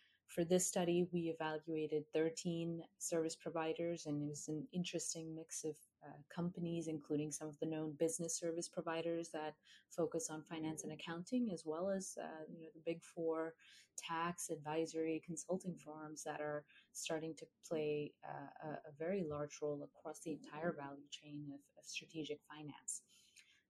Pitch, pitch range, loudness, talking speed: 160 Hz, 150-165 Hz, -44 LUFS, 160 wpm